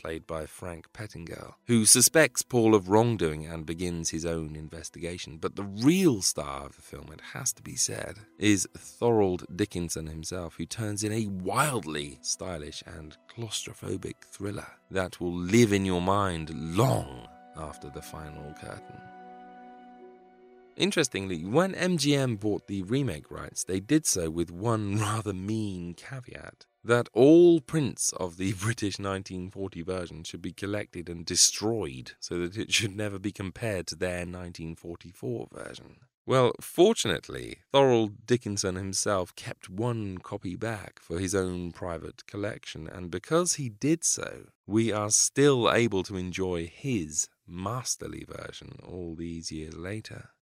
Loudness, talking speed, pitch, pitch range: -27 LUFS, 145 wpm, 95 Hz, 85-115 Hz